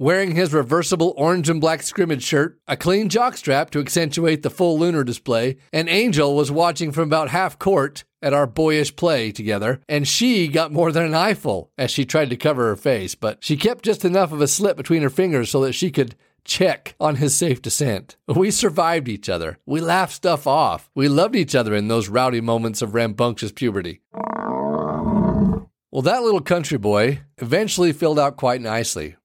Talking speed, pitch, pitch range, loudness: 190 wpm, 150 Hz, 130-175 Hz, -20 LUFS